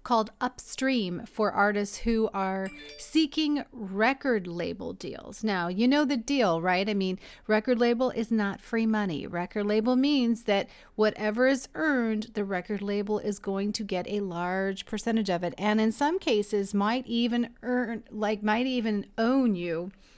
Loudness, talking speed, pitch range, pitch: -28 LUFS, 165 wpm, 200-240 Hz, 215 Hz